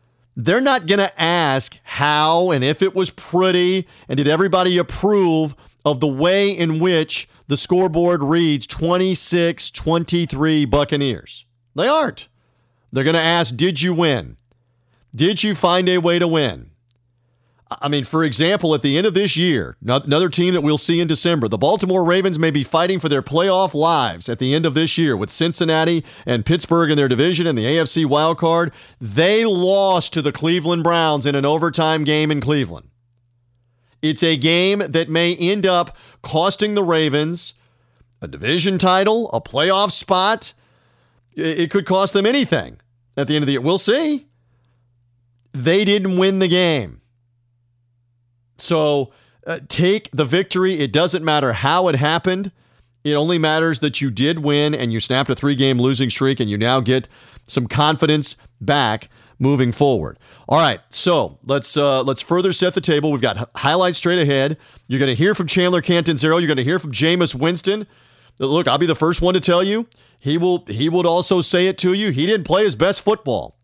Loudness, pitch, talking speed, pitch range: -17 LUFS, 160 Hz, 180 wpm, 135-180 Hz